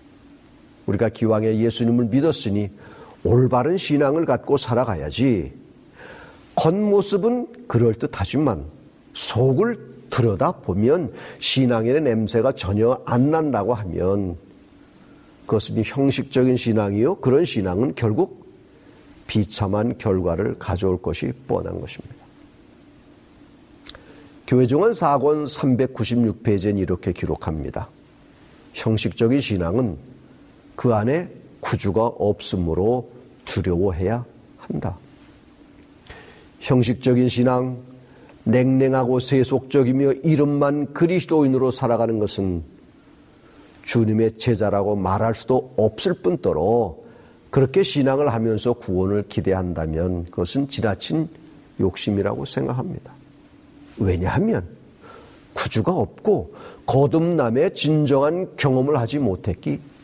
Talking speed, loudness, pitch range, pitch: 240 characters per minute, -21 LUFS, 105-140 Hz, 120 Hz